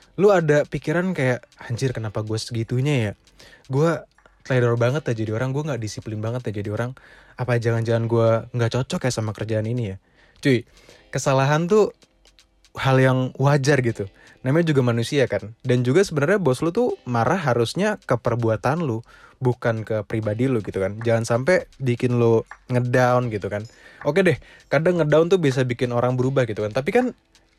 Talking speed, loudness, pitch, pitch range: 175 wpm, -22 LUFS, 125 Hz, 115-145 Hz